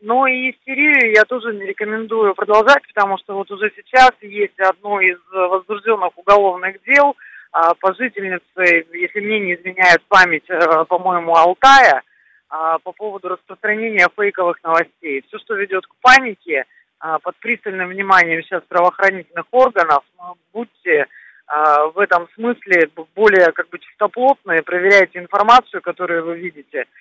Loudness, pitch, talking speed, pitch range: -15 LUFS, 190 Hz, 125 wpm, 175-215 Hz